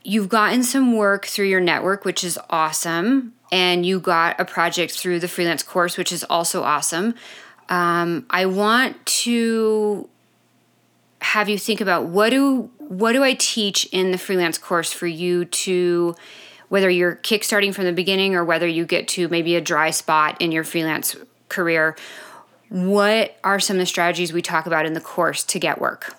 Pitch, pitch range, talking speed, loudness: 180 Hz, 170-210 Hz, 180 wpm, -19 LUFS